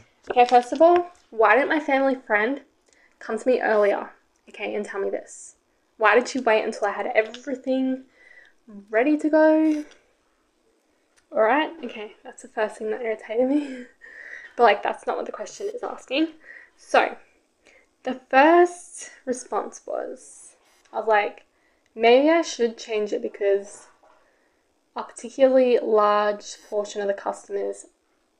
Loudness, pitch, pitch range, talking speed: -22 LUFS, 255 Hz, 215-315 Hz, 145 wpm